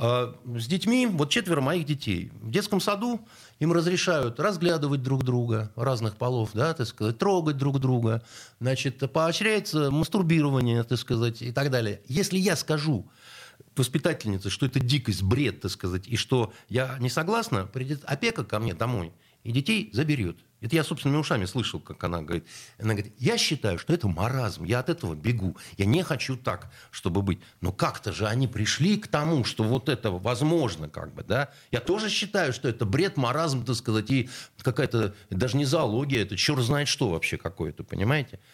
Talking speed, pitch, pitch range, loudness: 175 wpm, 130 Hz, 110-155 Hz, -27 LUFS